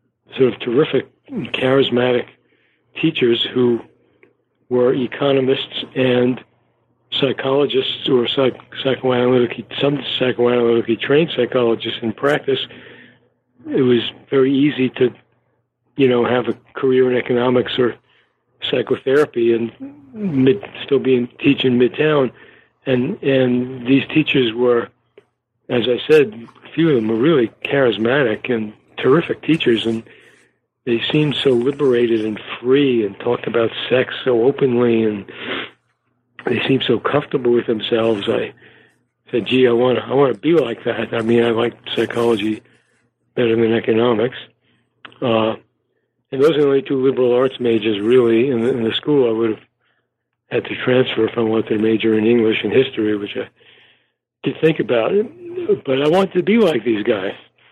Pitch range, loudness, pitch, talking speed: 115-135 Hz, -17 LUFS, 125 Hz, 145 wpm